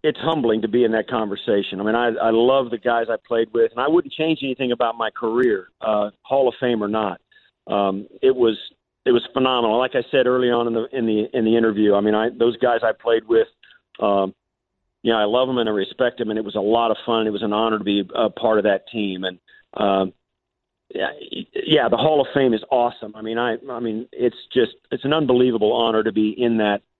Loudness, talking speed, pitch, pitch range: -20 LUFS, 245 wpm, 115 Hz, 105-125 Hz